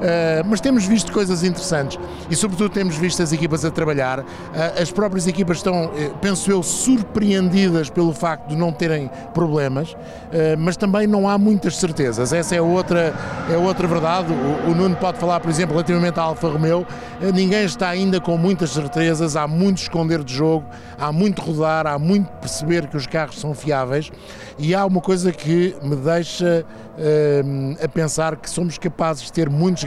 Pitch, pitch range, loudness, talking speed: 170 Hz, 155-185 Hz, -19 LUFS, 185 wpm